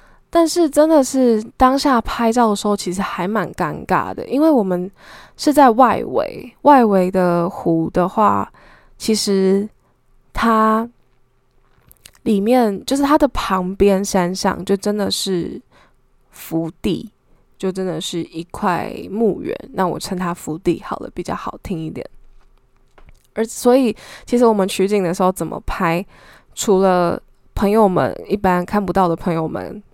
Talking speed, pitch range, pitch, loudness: 205 characters per minute, 175-230 Hz, 195 Hz, -17 LUFS